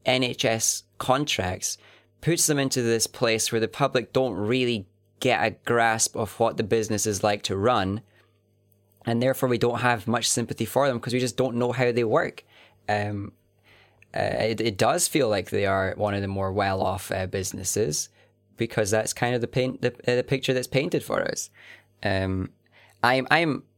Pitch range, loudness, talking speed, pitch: 105-125 Hz, -25 LUFS, 185 wpm, 115 Hz